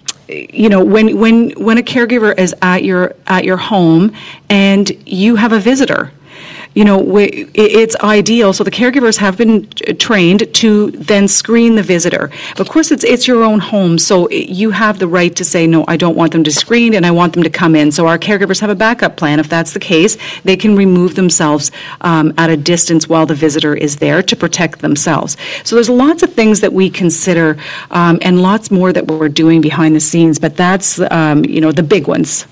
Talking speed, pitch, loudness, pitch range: 215 wpm, 185 Hz, -10 LUFS, 165-215 Hz